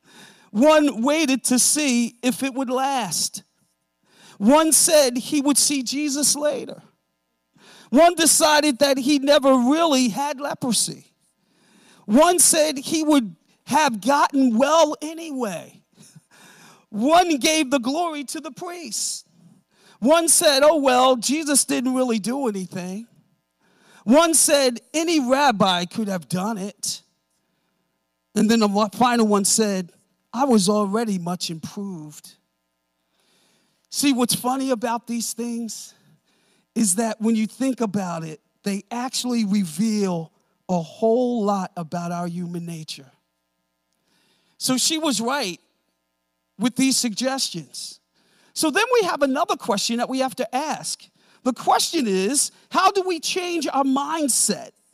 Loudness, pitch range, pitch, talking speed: -20 LUFS, 190-285 Hz, 235 Hz, 125 wpm